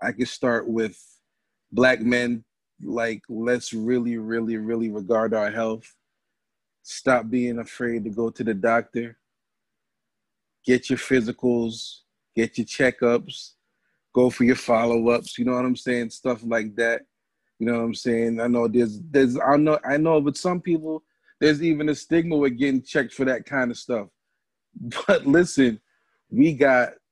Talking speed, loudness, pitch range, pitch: 160 wpm, -23 LUFS, 115-130 Hz, 120 Hz